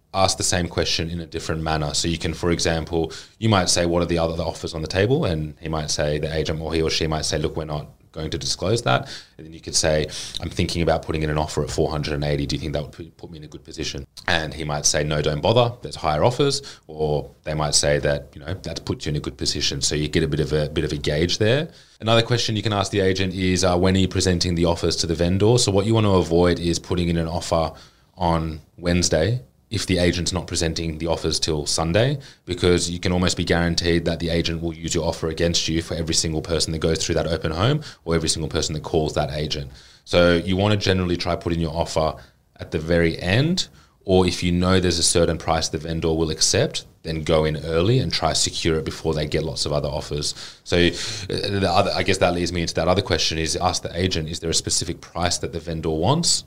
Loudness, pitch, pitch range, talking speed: -22 LUFS, 85 Hz, 80-90 Hz, 255 wpm